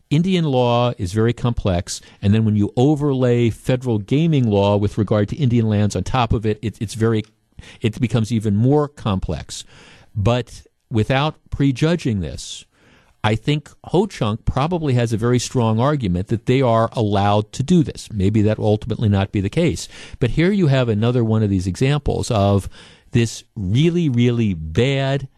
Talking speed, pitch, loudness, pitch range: 175 wpm, 115 Hz, -19 LUFS, 105-130 Hz